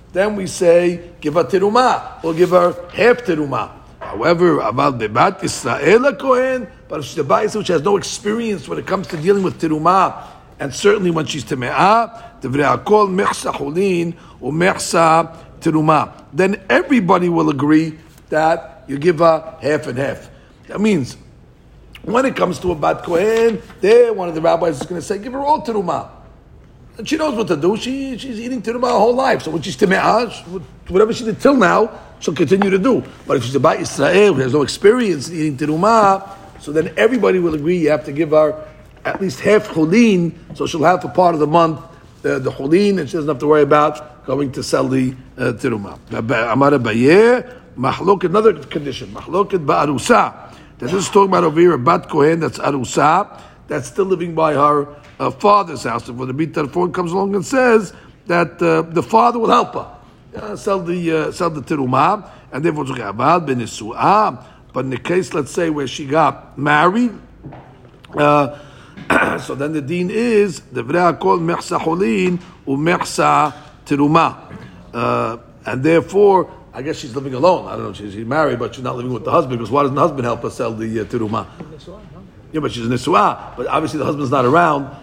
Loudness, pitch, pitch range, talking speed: -16 LUFS, 165 Hz, 145-195 Hz, 185 wpm